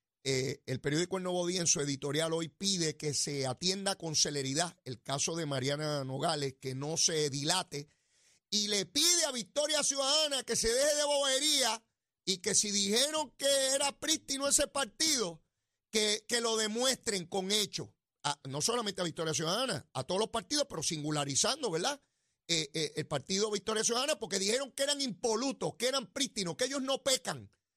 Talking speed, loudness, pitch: 175 wpm, -31 LUFS, 195 Hz